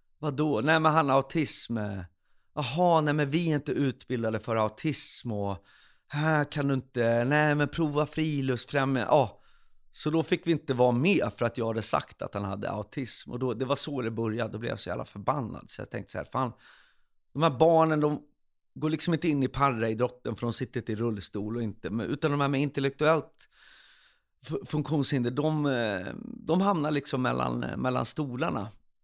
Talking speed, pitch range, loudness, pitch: 190 wpm, 115-150 Hz, -29 LUFS, 135 Hz